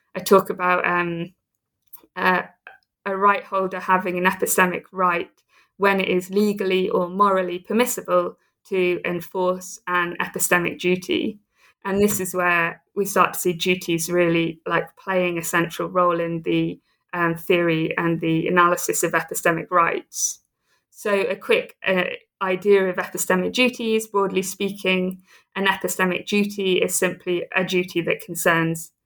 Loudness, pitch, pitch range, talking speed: -21 LUFS, 185 Hz, 175-195 Hz, 140 wpm